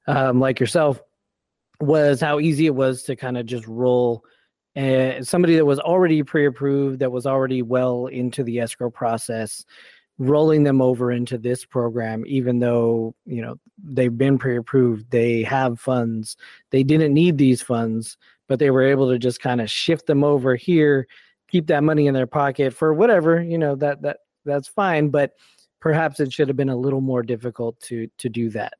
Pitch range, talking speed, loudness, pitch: 120-145 Hz, 185 wpm, -20 LUFS, 130 Hz